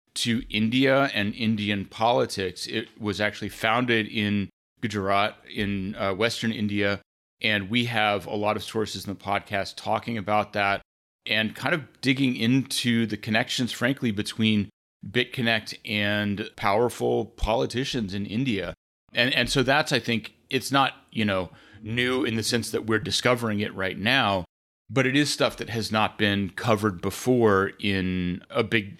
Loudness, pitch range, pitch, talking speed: -25 LUFS, 100-120 Hz, 110 Hz, 155 wpm